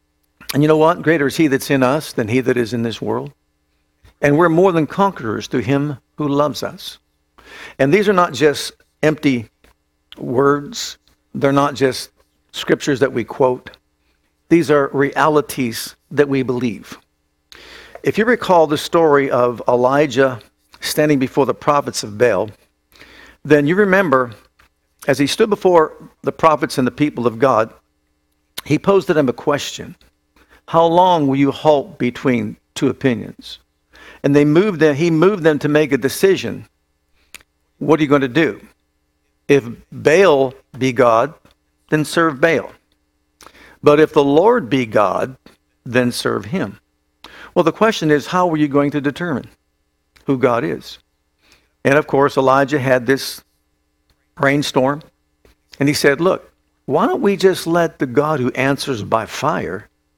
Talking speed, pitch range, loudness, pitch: 155 wpm, 115-155 Hz, -16 LUFS, 140 Hz